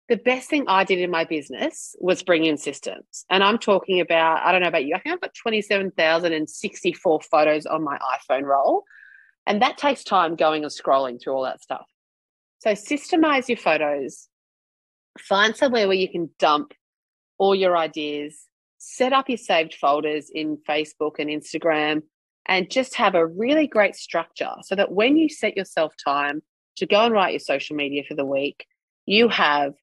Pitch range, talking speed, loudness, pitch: 150-215 Hz, 180 wpm, -22 LUFS, 175 Hz